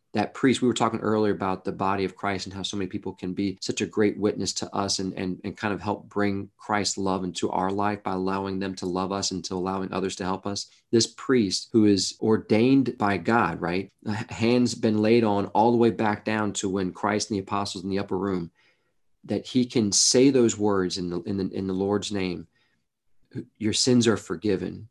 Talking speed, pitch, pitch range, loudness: 225 wpm, 100 Hz, 95-110 Hz, -25 LUFS